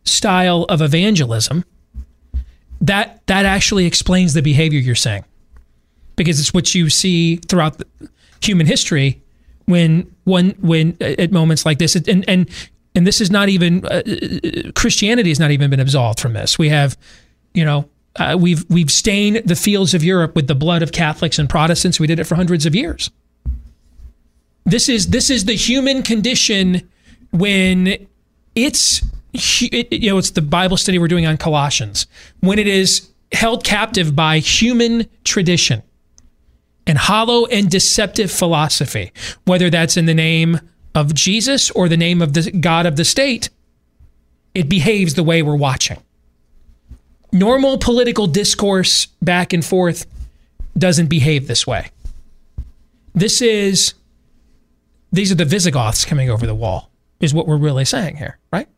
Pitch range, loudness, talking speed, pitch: 130-190 Hz, -15 LUFS, 155 wpm, 170 Hz